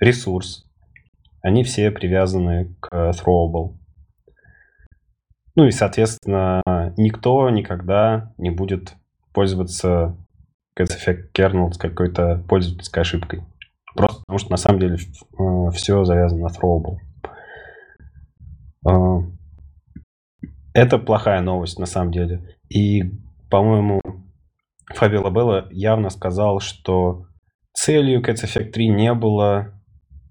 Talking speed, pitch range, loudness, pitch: 100 wpm, 85-100 Hz, -19 LUFS, 90 Hz